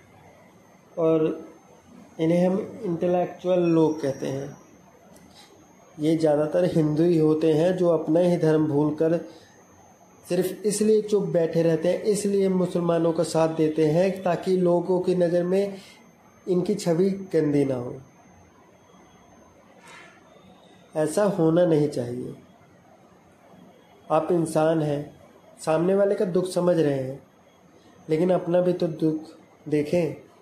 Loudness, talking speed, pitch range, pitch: -23 LUFS, 120 wpm, 155-180 Hz, 170 Hz